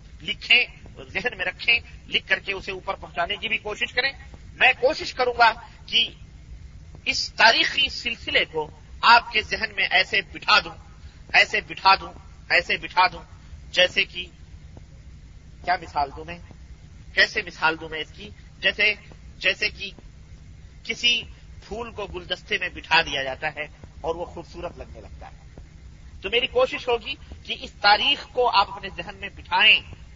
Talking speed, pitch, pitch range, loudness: 160 wpm, 190 Hz, 150-220 Hz, -21 LUFS